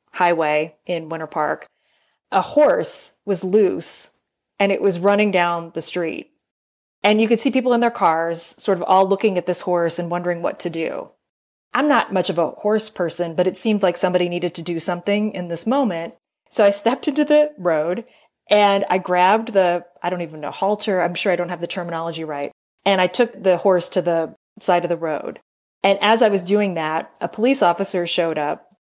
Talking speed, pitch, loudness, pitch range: 205 wpm, 180 Hz, -19 LUFS, 170-205 Hz